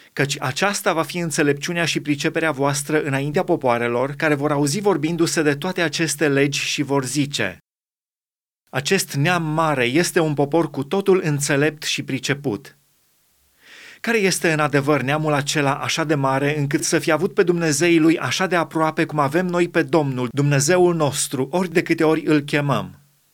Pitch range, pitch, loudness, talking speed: 145-170 Hz, 155 Hz, -20 LUFS, 165 wpm